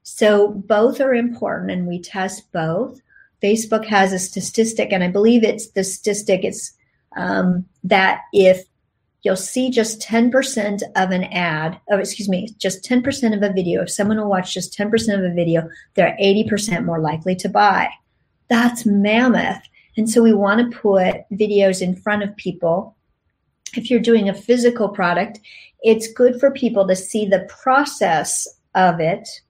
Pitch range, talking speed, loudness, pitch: 185-225 Hz, 165 wpm, -18 LUFS, 205 Hz